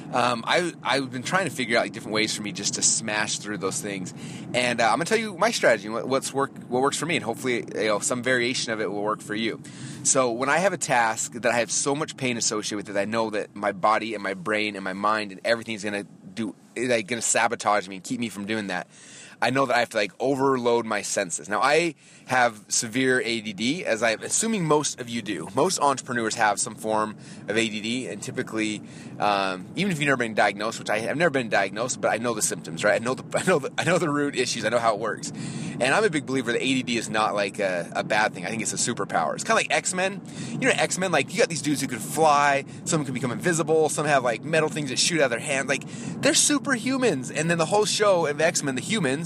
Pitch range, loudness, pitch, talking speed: 110-155 Hz, -24 LUFS, 130 Hz, 265 wpm